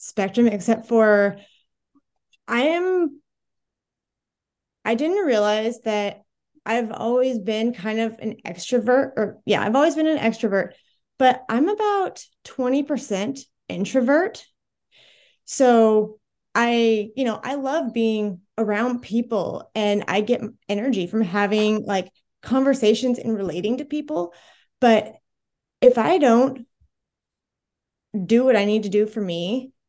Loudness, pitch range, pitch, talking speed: -21 LUFS, 210-265 Hz, 230 Hz, 120 wpm